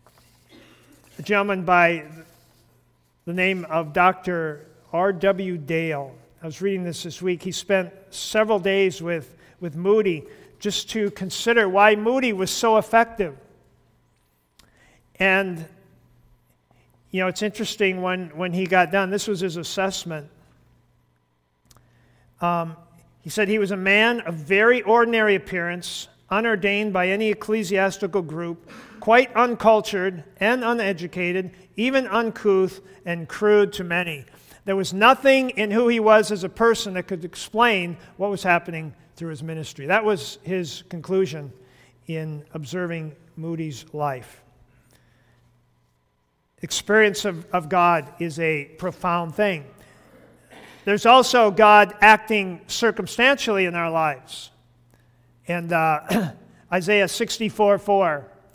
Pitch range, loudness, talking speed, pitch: 160-205 Hz, -21 LUFS, 120 wpm, 185 Hz